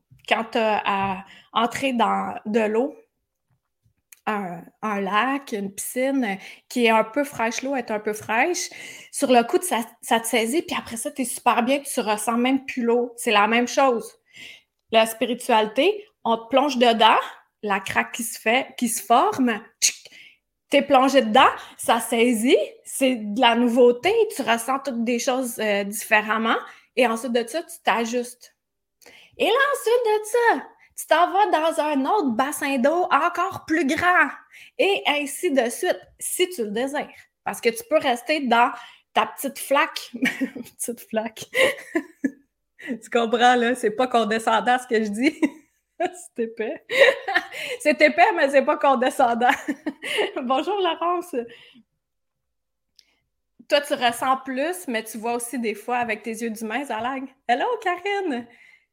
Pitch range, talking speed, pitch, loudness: 230-300 Hz, 160 wpm, 255 Hz, -22 LUFS